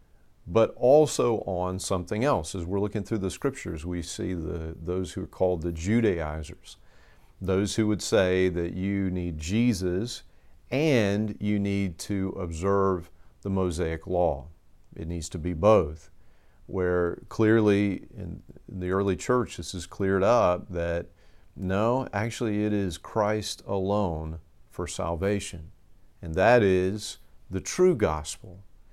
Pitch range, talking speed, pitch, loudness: 85-105 Hz, 135 wpm, 95 Hz, -27 LUFS